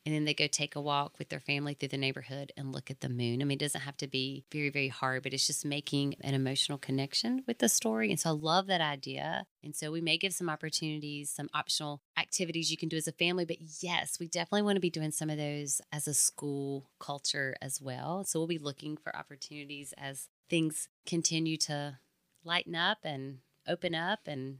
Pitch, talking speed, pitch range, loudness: 150 Hz, 225 wpm, 140-165 Hz, -33 LUFS